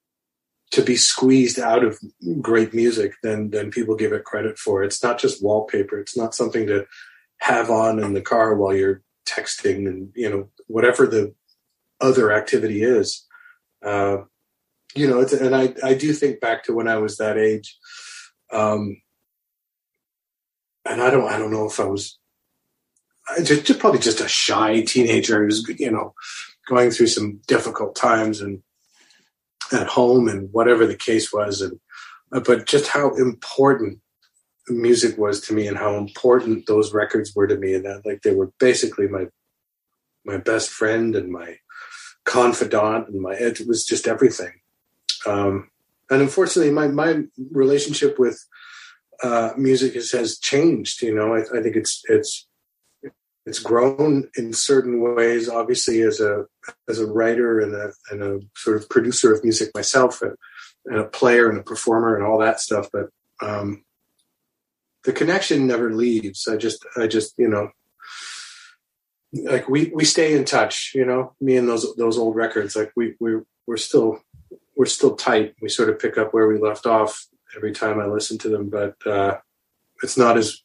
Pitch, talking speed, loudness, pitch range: 115 Hz, 170 wpm, -20 LUFS, 105-135 Hz